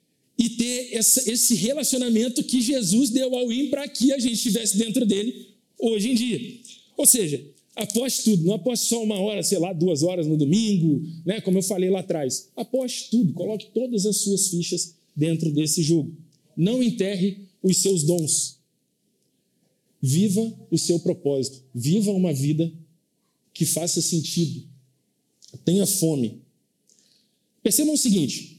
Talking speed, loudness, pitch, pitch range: 150 wpm, -22 LUFS, 200 Hz, 165-230 Hz